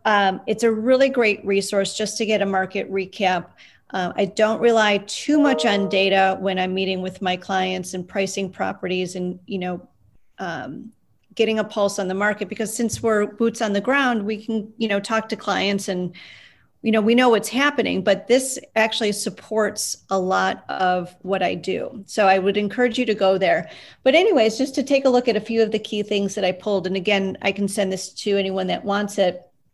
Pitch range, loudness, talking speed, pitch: 190-220 Hz, -21 LUFS, 215 wpm, 205 Hz